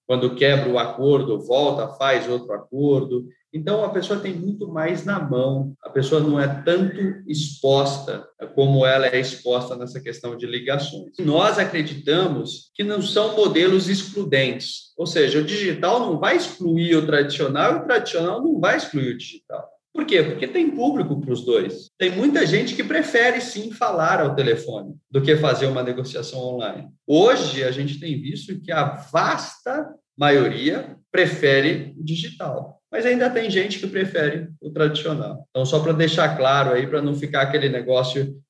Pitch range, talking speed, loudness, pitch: 135-195 Hz, 170 wpm, -21 LUFS, 155 Hz